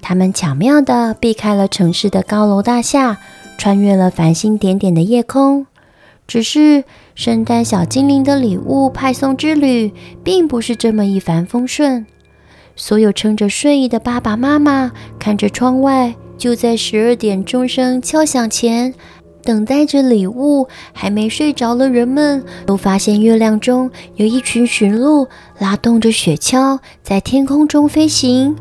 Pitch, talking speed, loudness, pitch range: 240 Hz, 225 characters per minute, -13 LUFS, 210-270 Hz